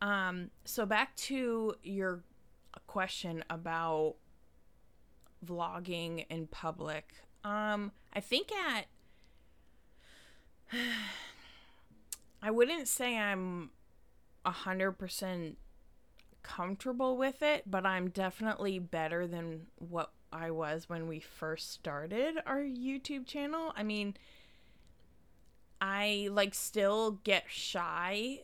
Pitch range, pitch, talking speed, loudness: 160-215 Hz, 185 Hz, 95 wpm, -36 LUFS